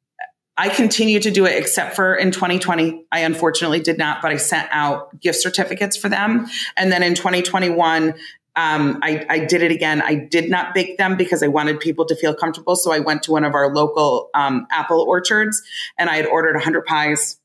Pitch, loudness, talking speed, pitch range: 170 Hz, -17 LUFS, 205 wpm, 155-190 Hz